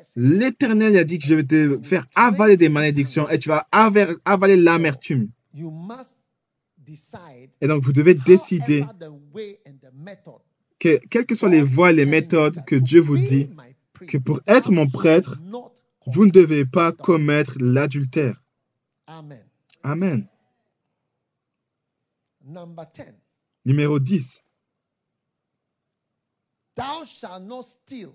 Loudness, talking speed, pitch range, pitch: -17 LUFS, 100 wpm, 145-185 Hz, 160 Hz